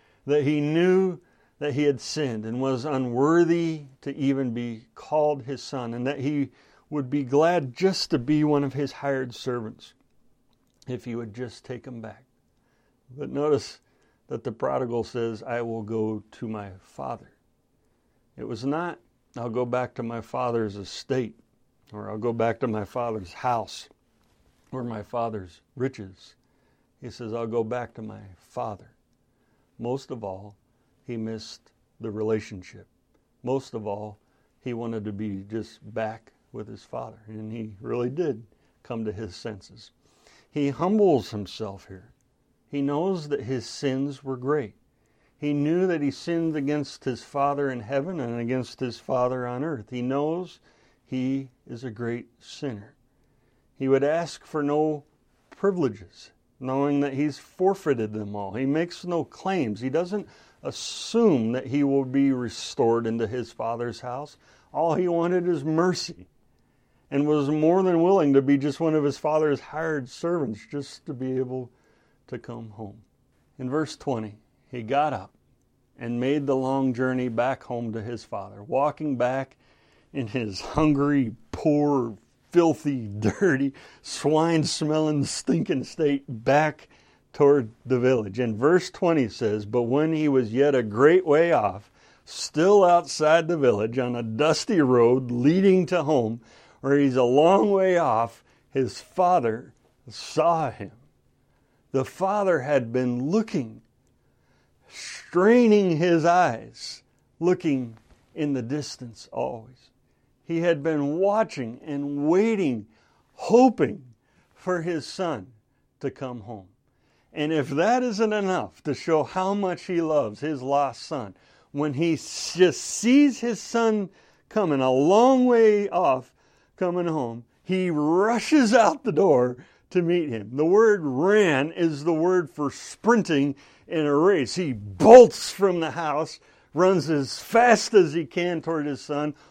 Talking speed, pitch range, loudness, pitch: 150 wpm, 120-160 Hz, -24 LUFS, 135 Hz